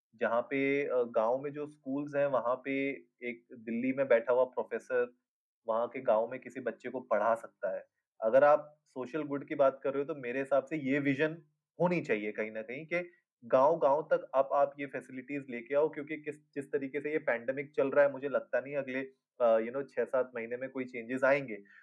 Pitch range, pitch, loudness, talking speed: 130-150 Hz, 140 Hz, -32 LUFS, 215 wpm